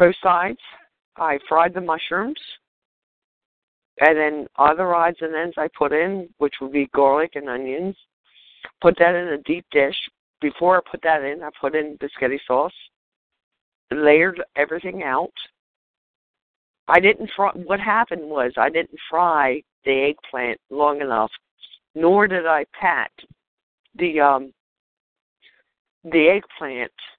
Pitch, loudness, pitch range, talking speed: 160 Hz, -20 LUFS, 145-175 Hz, 135 wpm